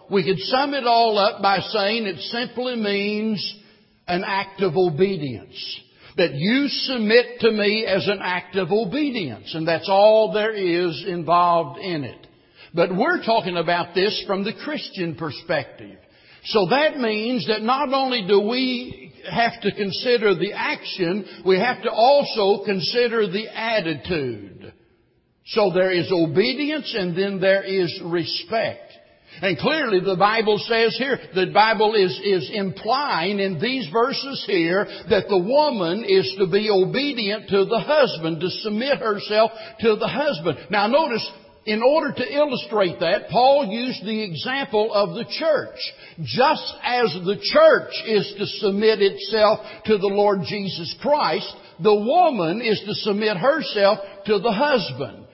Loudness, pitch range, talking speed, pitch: -21 LUFS, 190-230 Hz, 150 wpm, 205 Hz